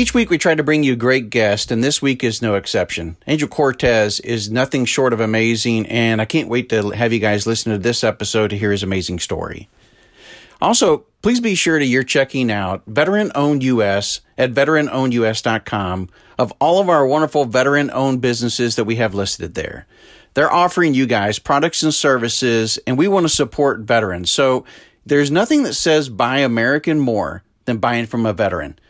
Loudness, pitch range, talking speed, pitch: -17 LUFS, 110-145 Hz, 185 wpm, 120 Hz